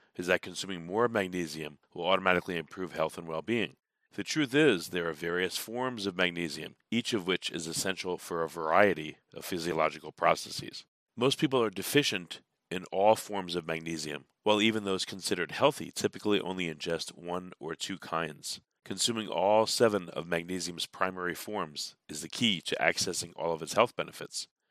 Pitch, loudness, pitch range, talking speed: 90 Hz, -31 LUFS, 85-105 Hz, 170 wpm